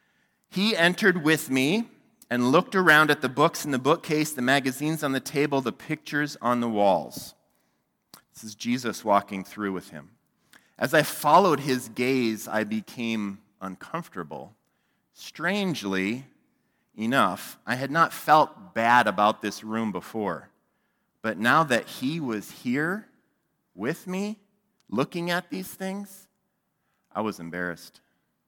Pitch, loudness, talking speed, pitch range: 135 Hz, -25 LUFS, 135 wpm, 110-175 Hz